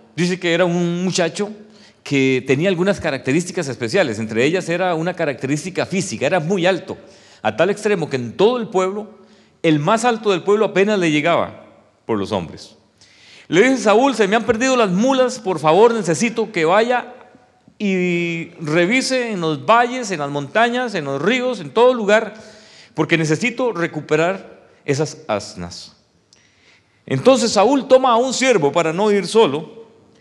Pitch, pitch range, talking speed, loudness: 190 Hz, 160-225 Hz, 160 wpm, -17 LUFS